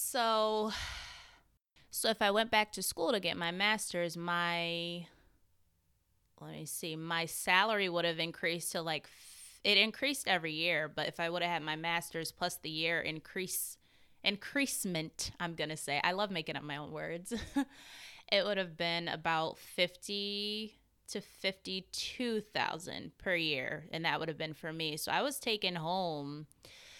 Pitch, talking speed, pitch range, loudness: 175 Hz, 165 wpm, 160-205 Hz, -34 LUFS